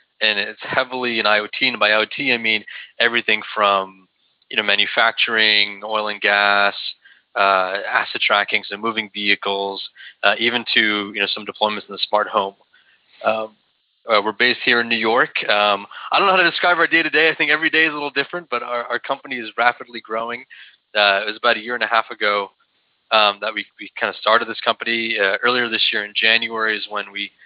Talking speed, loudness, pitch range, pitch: 210 wpm, -17 LUFS, 100-120 Hz, 110 Hz